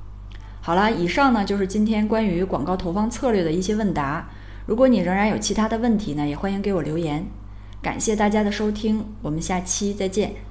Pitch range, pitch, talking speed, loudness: 150-215 Hz, 195 Hz, 310 characters per minute, -22 LUFS